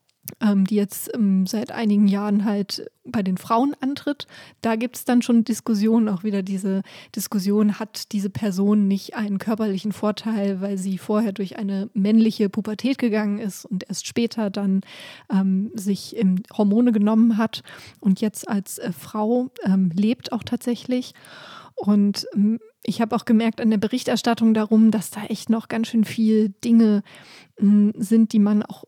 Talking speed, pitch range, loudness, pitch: 165 wpm, 200-225 Hz, -22 LUFS, 215 Hz